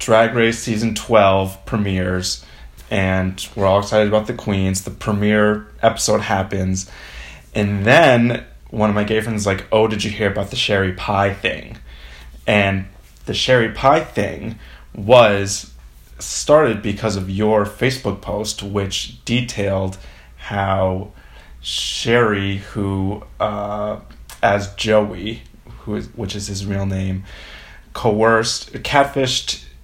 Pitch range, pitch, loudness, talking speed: 95-110 Hz, 100 Hz, -18 LUFS, 125 wpm